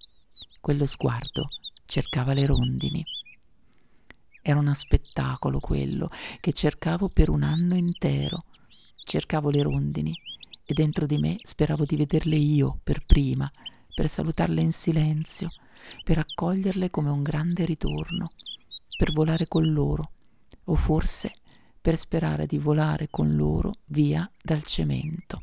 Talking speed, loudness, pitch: 125 wpm, -26 LUFS, 150 Hz